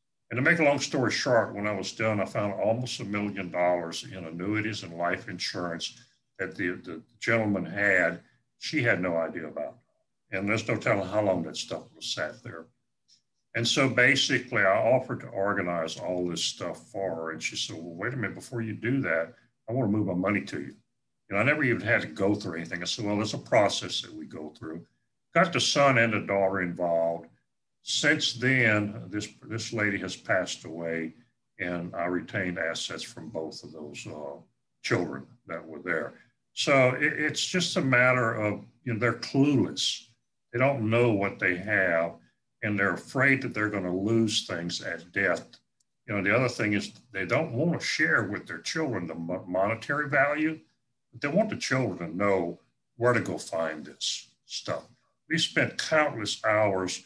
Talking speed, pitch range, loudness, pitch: 195 wpm, 90-125 Hz, -27 LUFS, 105 Hz